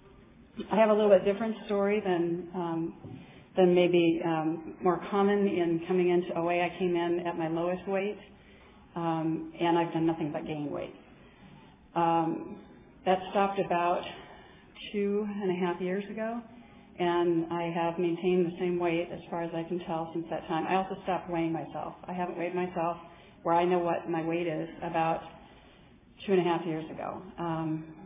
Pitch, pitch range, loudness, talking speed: 175 Hz, 165-190 Hz, -30 LUFS, 180 wpm